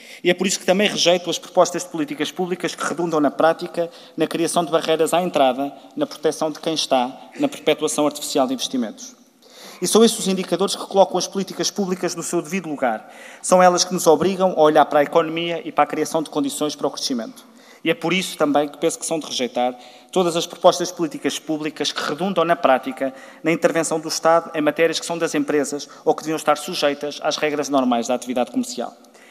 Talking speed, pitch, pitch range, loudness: 220 wpm, 165 Hz, 150-180 Hz, -20 LUFS